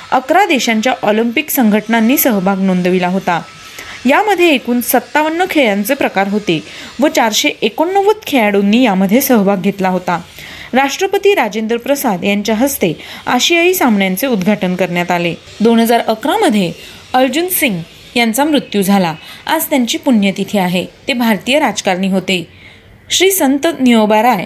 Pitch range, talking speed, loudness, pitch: 195-280 Hz, 125 wpm, -13 LUFS, 235 Hz